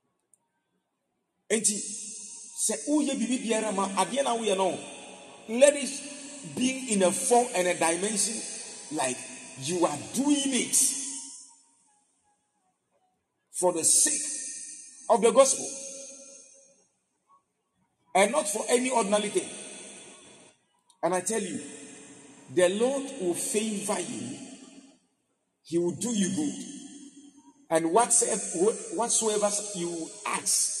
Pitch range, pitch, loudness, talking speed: 200-275 Hz, 240 Hz, -26 LUFS, 90 wpm